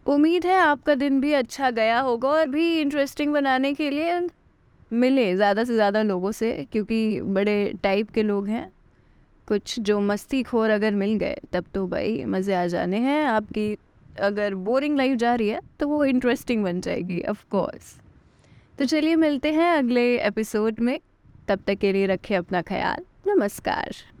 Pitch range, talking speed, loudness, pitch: 205-285 Hz, 170 wpm, -23 LUFS, 230 Hz